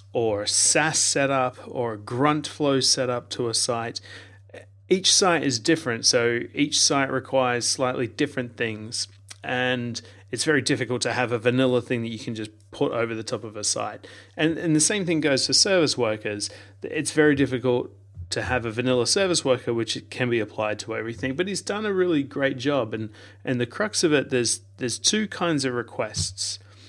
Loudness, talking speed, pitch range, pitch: -23 LUFS, 190 wpm, 110-140 Hz, 125 Hz